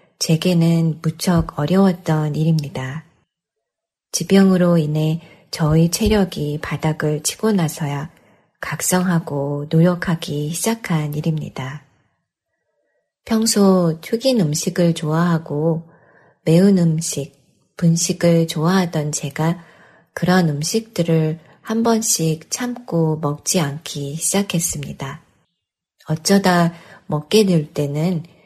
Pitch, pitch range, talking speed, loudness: 165 Hz, 155-180 Hz, 210 characters per minute, -18 LUFS